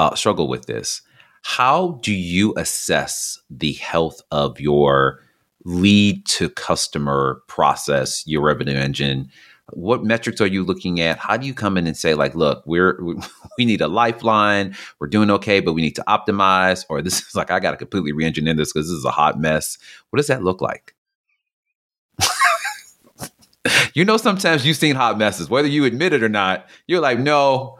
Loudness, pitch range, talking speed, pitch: -18 LUFS, 80-120 Hz, 180 wpm, 95 Hz